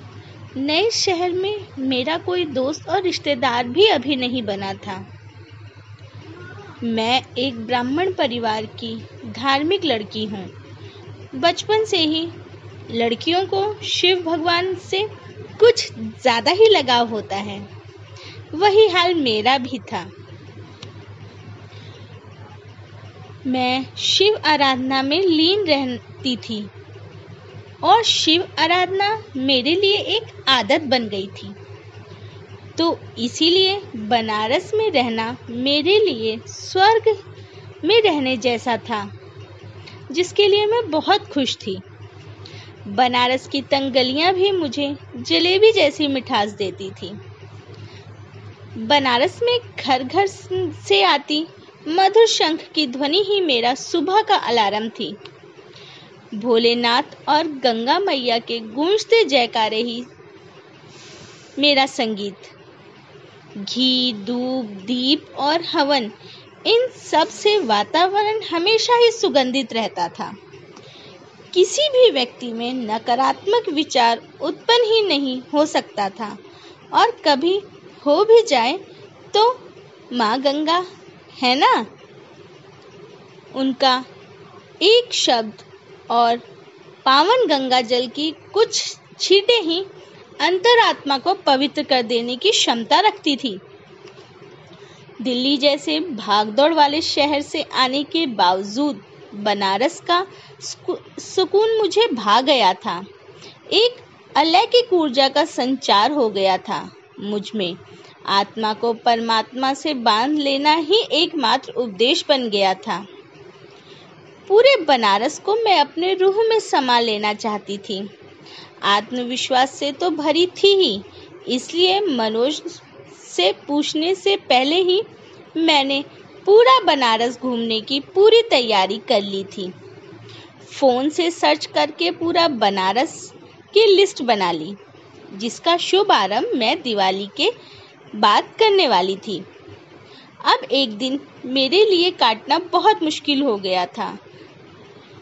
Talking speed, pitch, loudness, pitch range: 110 wpm, 275 Hz, -18 LUFS, 215-360 Hz